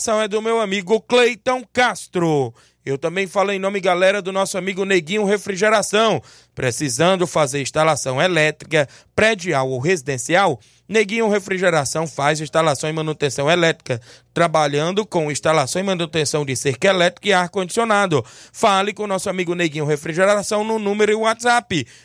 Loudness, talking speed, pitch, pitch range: -19 LUFS, 140 wpm, 180 Hz, 155-205 Hz